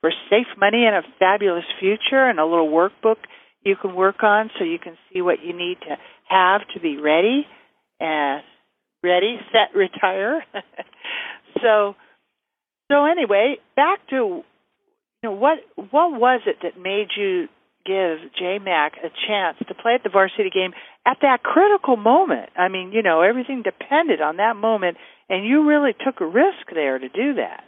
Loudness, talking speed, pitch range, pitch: -19 LUFS, 170 wpm, 190-305 Hz, 220 Hz